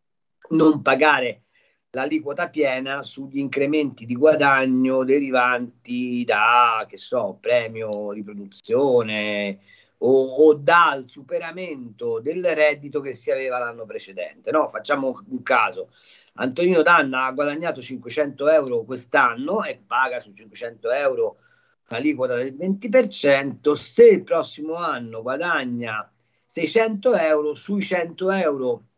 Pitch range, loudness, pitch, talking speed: 130-205 Hz, -21 LUFS, 150 Hz, 110 wpm